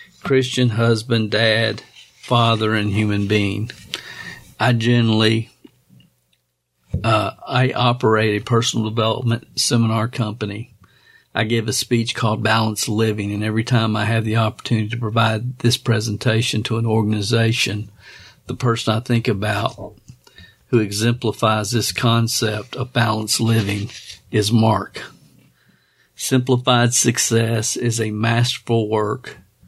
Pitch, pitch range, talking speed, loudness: 110 Hz, 110-120 Hz, 115 wpm, -19 LUFS